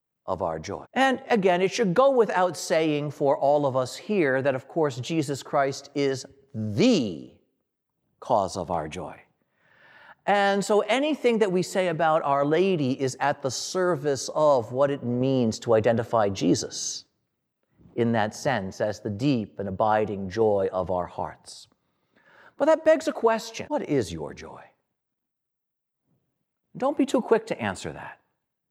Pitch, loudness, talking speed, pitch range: 145 Hz, -25 LUFS, 155 wpm, 125-200 Hz